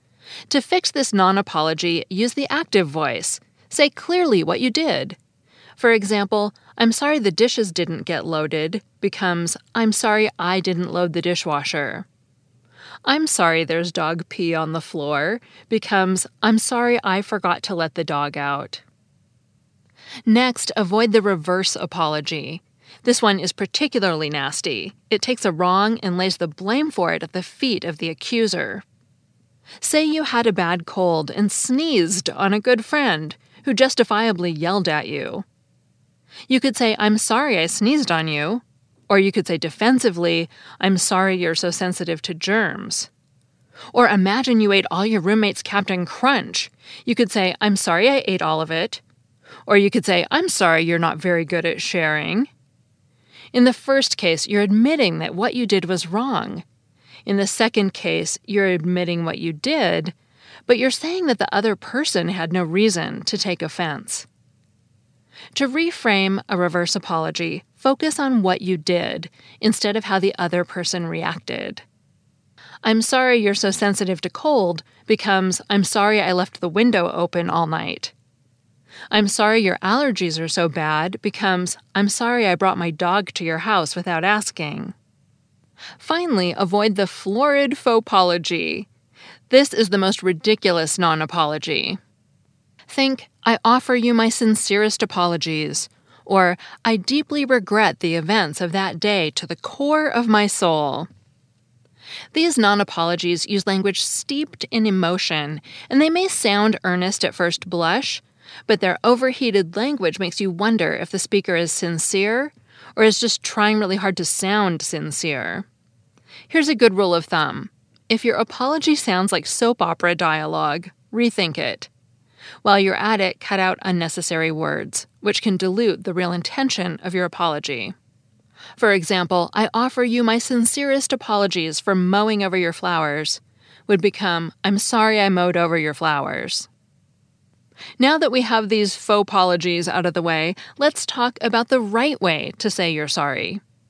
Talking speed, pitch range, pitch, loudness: 155 wpm, 170-225 Hz, 195 Hz, -19 LUFS